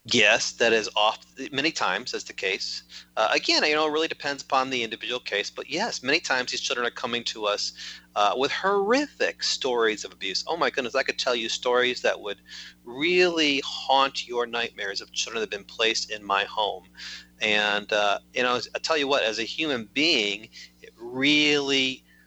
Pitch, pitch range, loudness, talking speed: 125 Hz, 105-145 Hz, -24 LUFS, 195 wpm